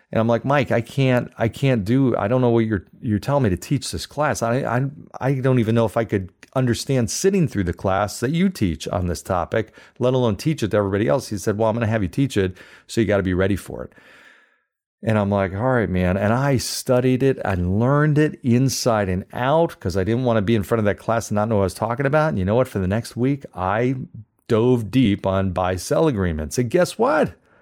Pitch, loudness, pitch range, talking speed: 115 Hz, -21 LUFS, 100-130 Hz, 255 wpm